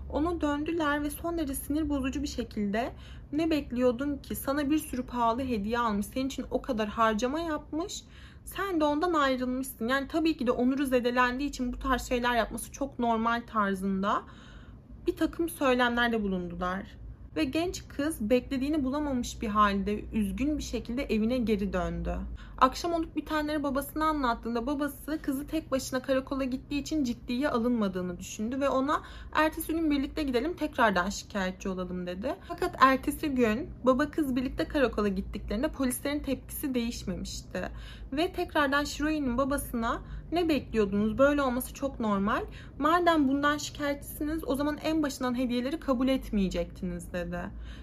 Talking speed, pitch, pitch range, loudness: 145 wpm, 265 Hz, 230-295 Hz, -30 LUFS